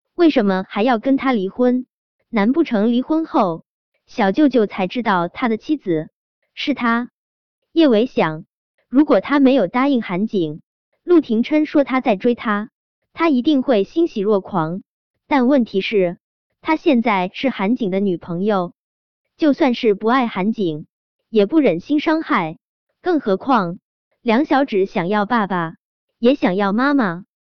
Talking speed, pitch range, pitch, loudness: 210 characters per minute, 195-280 Hz, 235 Hz, -18 LUFS